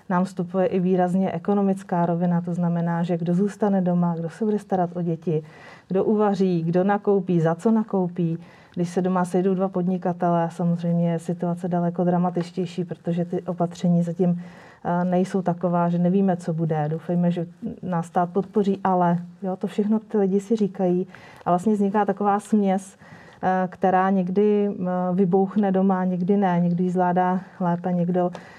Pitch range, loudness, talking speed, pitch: 175-195 Hz, -23 LUFS, 155 wpm, 180 Hz